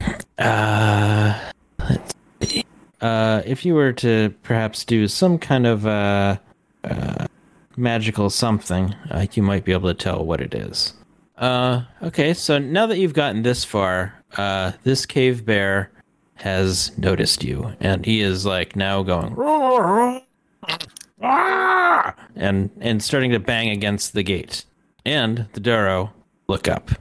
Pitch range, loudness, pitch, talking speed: 100-130 Hz, -20 LUFS, 110 Hz, 140 wpm